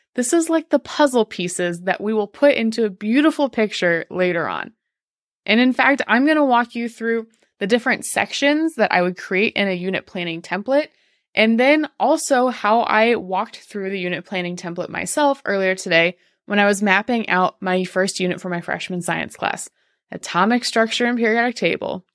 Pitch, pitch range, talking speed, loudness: 215 Hz, 185-250 Hz, 185 wpm, -19 LUFS